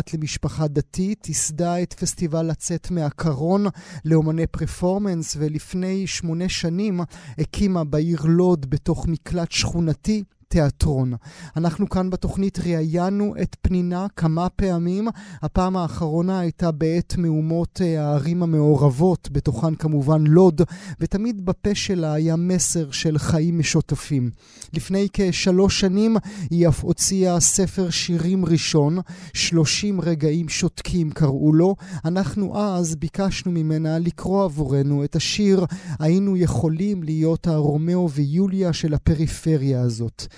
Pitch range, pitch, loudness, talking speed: 155-185 Hz, 165 Hz, -21 LUFS, 110 wpm